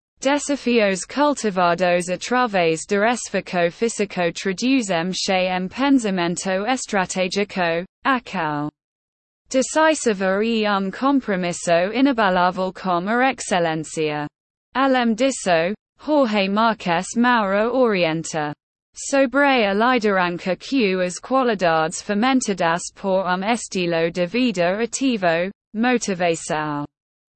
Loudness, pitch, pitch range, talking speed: -20 LUFS, 195 Hz, 175-245 Hz, 90 wpm